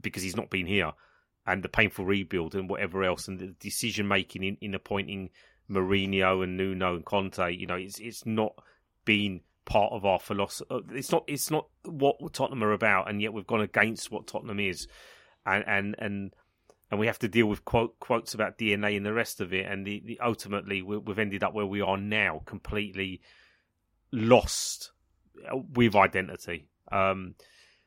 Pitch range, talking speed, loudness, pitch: 95-110 Hz, 180 wpm, -29 LUFS, 100 Hz